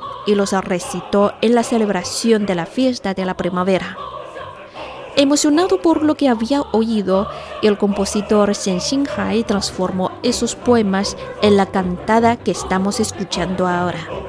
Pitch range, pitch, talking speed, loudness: 190-235 Hz, 205 Hz, 135 wpm, -17 LUFS